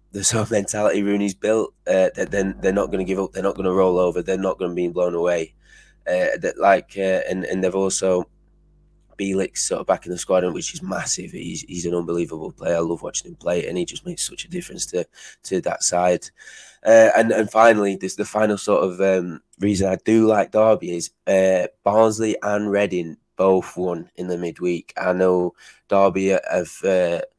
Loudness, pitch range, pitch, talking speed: -21 LUFS, 90-105 Hz, 95 Hz, 210 wpm